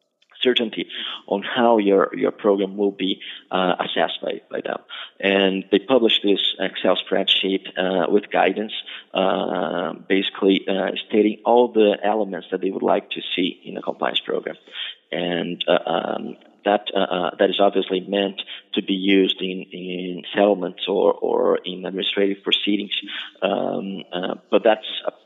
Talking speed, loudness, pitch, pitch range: 155 wpm, -21 LUFS, 100 Hz, 95-105 Hz